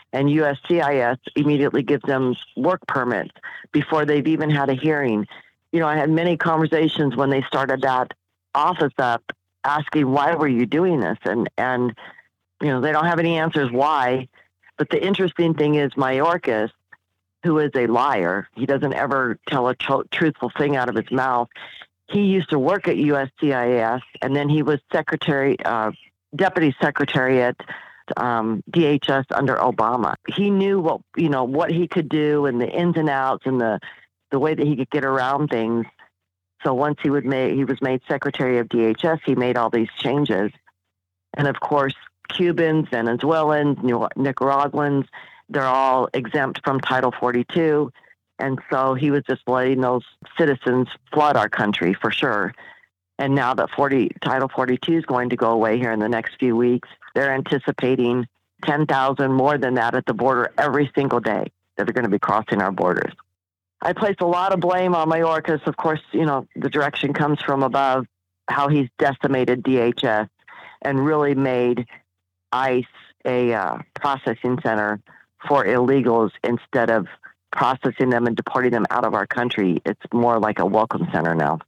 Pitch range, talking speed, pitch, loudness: 120-150 Hz, 170 wpm, 135 Hz, -21 LUFS